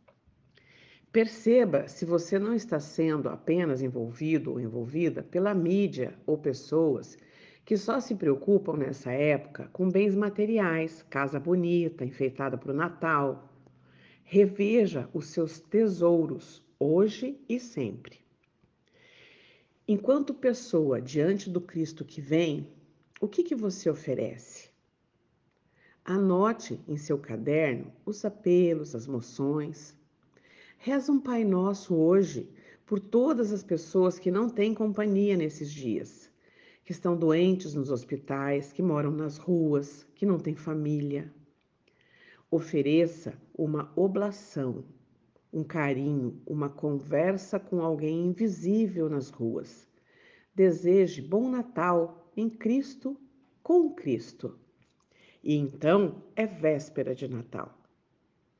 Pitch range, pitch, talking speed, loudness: 145-200 Hz, 165 Hz, 110 wpm, -29 LUFS